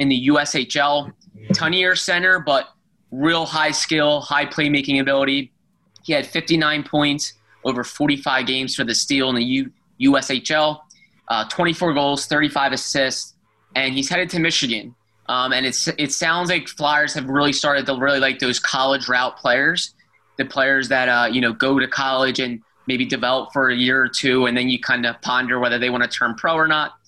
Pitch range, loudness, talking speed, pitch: 130-155 Hz, -19 LUFS, 185 wpm, 140 Hz